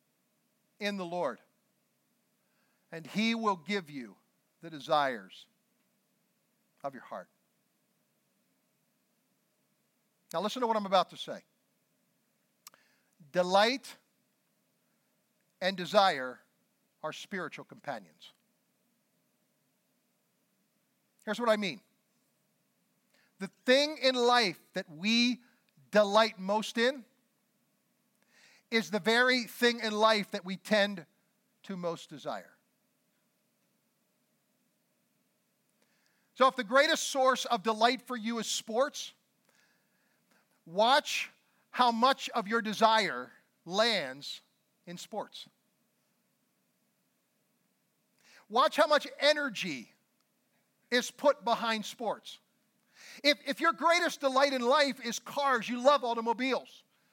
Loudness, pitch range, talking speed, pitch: -29 LUFS, 200-245 Hz, 95 wpm, 220 Hz